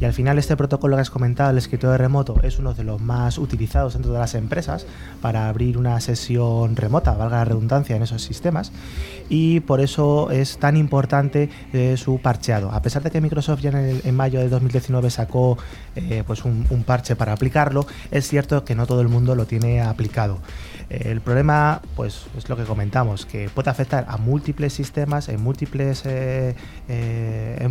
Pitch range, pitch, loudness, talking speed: 115-140 Hz, 125 Hz, -21 LUFS, 195 wpm